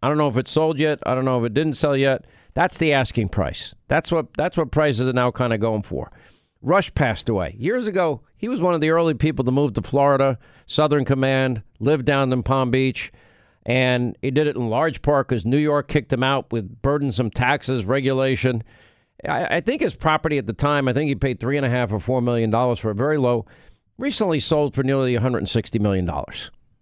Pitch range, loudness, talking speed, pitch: 120-150 Hz, -21 LUFS, 235 wpm, 135 Hz